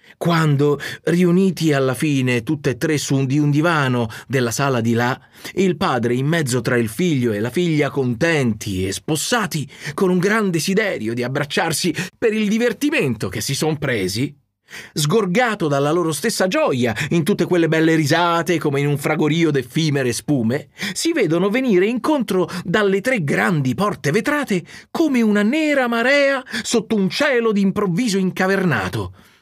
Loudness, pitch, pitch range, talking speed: -19 LUFS, 160 Hz, 135-195 Hz, 155 wpm